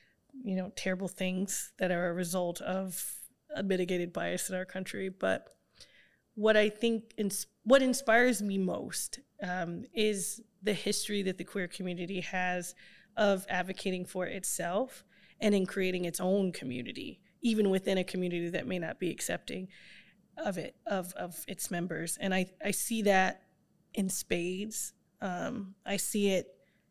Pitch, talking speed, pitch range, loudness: 190 Hz, 155 wpm, 185-205 Hz, -33 LUFS